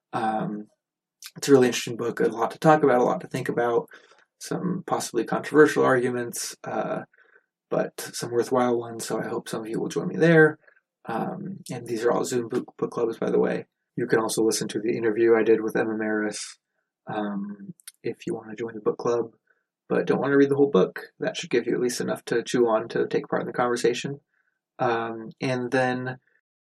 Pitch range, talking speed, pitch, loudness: 115-145 Hz, 215 wpm, 125 Hz, -25 LUFS